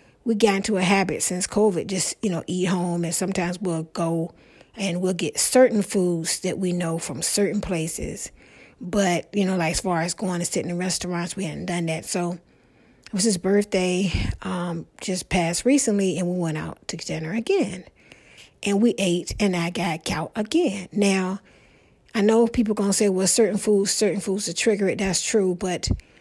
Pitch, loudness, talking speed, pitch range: 185 Hz, -23 LUFS, 195 wpm, 175-205 Hz